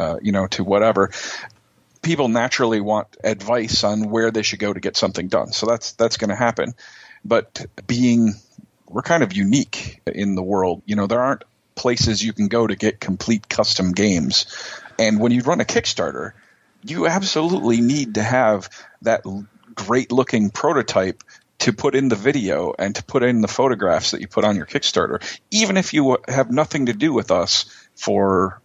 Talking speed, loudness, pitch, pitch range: 190 wpm, -19 LUFS, 115 Hz, 105-125 Hz